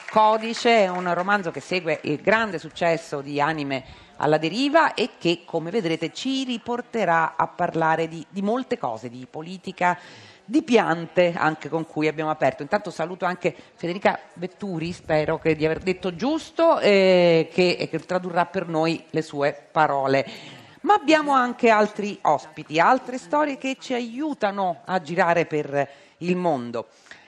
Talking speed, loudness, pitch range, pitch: 150 wpm, -23 LUFS, 155-215 Hz, 175 Hz